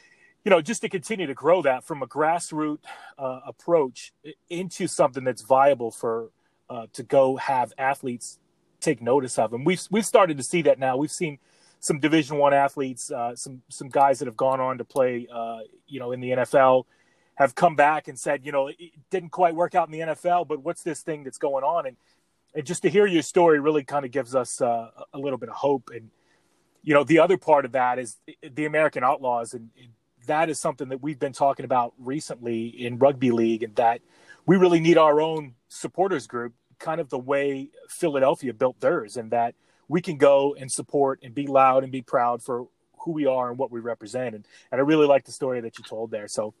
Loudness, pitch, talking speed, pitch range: -24 LUFS, 140 Hz, 220 wpm, 125-160 Hz